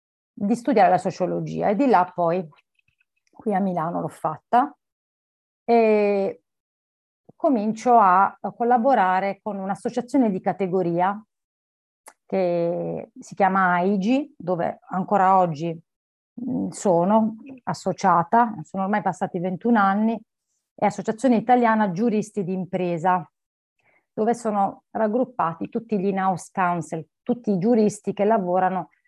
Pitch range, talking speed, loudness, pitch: 180-225 Hz, 110 wpm, -22 LUFS, 195 Hz